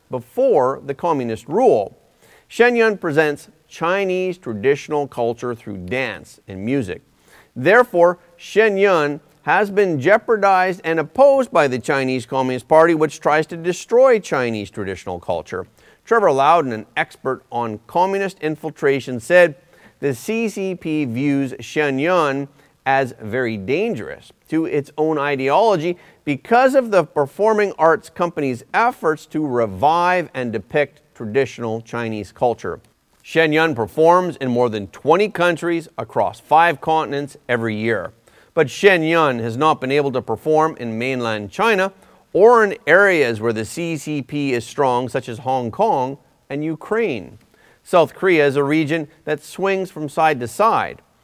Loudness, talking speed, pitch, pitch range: -18 LUFS, 140 wpm, 150 Hz, 125-175 Hz